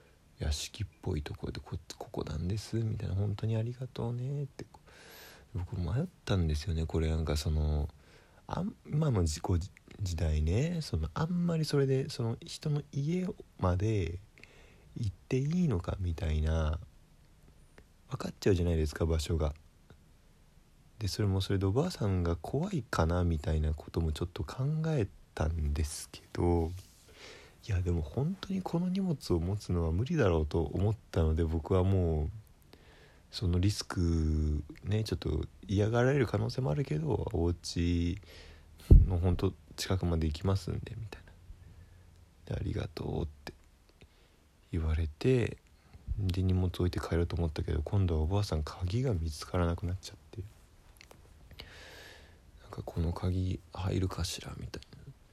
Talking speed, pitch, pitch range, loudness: 295 characters per minute, 90 Hz, 80-110 Hz, -33 LUFS